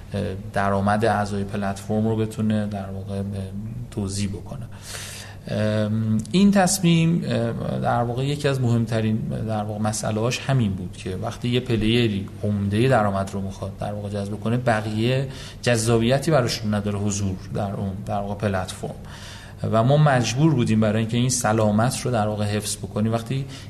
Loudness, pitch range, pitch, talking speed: -23 LUFS, 100-120 Hz, 110 Hz, 140 wpm